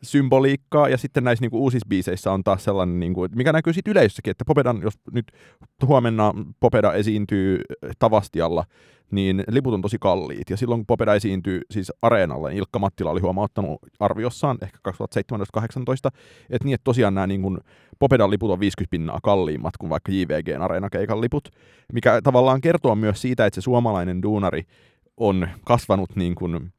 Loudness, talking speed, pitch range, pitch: -22 LUFS, 170 wpm, 95-125 Hz, 105 Hz